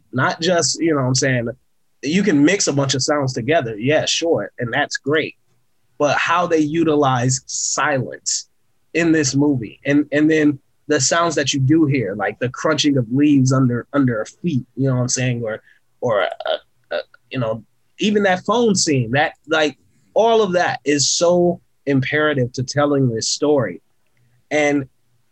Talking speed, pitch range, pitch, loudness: 180 wpm, 125-155 Hz, 140 Hz, -18 LUFS